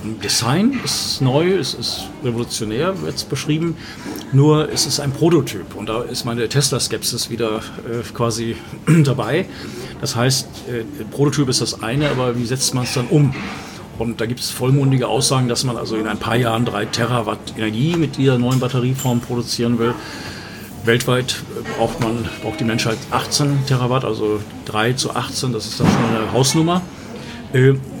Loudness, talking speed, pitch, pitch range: -19 LUFS, 170 wpm, 120 Hz, 115-135 Hz